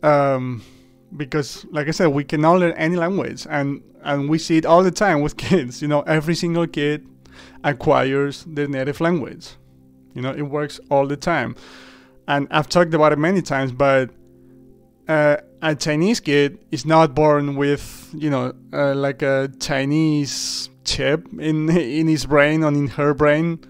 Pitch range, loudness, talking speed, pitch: 140-160 Hz, -19 LUFS, 170 wpm, 150 Hz